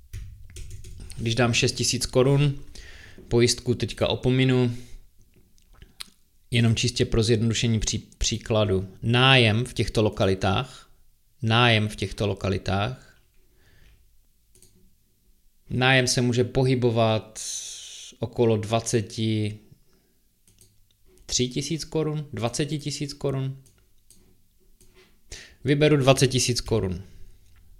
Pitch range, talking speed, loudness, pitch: 100-125 Hz, 80 wpm, -23 LUFS, 115 Hz